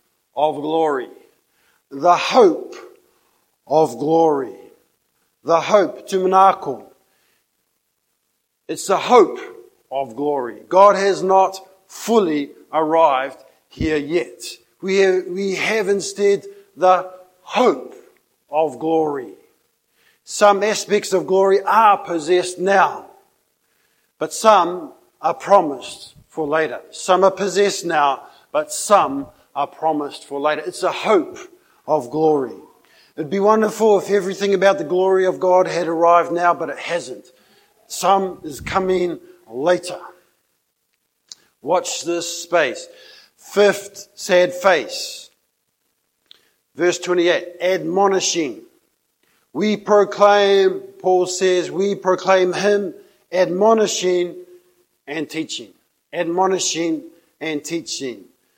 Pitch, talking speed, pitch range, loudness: 190 Hz, 100 wpm, 170-205 Hz, -18 LUFS